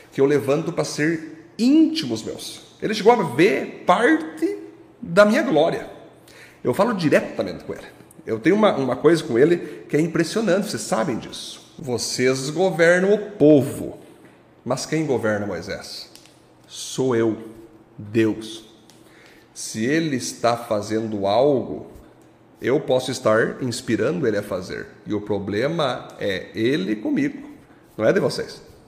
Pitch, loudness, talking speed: 150 Hz, -21 LUFS, 135 wpm